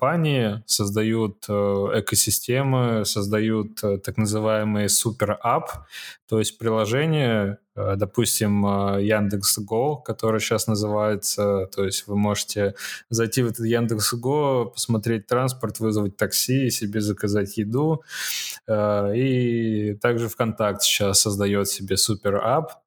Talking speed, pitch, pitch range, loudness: 110 wpm, 110 Hz, 105-115 Hz, -22 LUFS